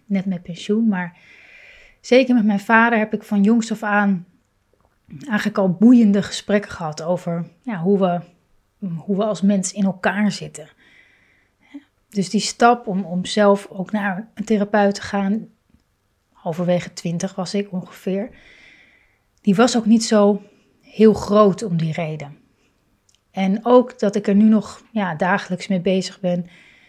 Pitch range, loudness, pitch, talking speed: 185-215 Hz, -19 LUFS, 200 Hz, 155 wpm